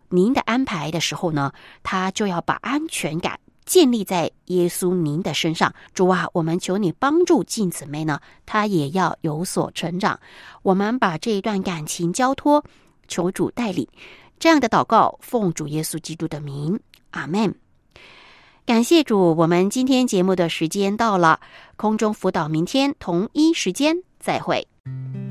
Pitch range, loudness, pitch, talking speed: 165-230 Hz, -21 LUFS, 185 Hz, 230 characters per minute